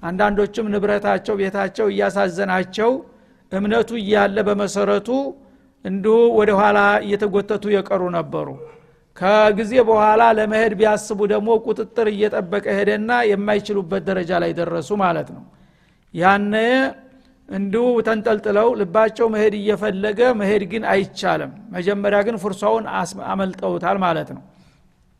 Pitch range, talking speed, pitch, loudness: 200-220 Hz, 100 wpm, 210 Hz, -19 LUFS